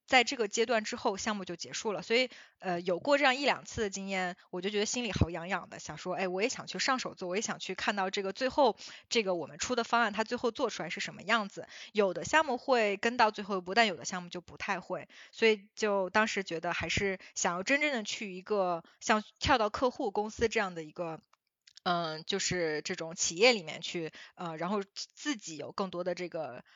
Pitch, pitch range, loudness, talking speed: 200 Hz, 180-230 Hz, -32 LUFS, 325 characters per minute